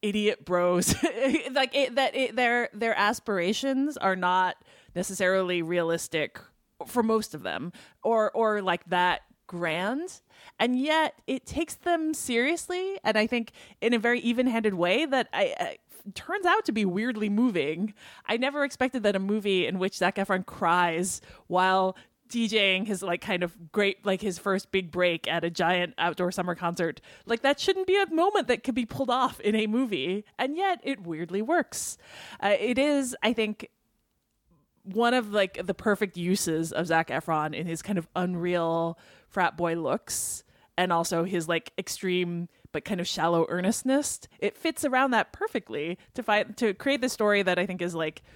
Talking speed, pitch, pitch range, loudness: 175 wpm, 205 Hz, 180-250 Hz, -27 LUFS